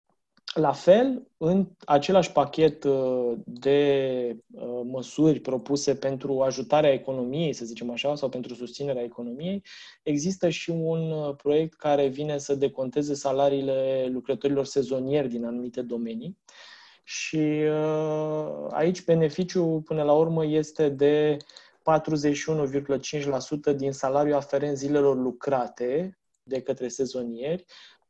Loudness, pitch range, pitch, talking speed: -26 LUFS, 130-155 Hz, 140 Hz, 105 wpm